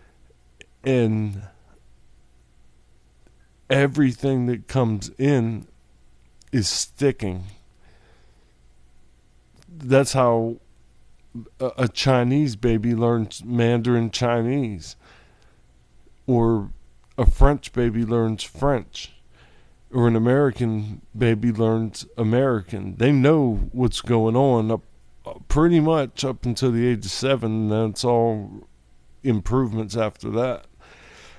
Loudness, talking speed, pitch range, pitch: -22 LUFS, 90 wpm, 100-130 Hz, 115 Hz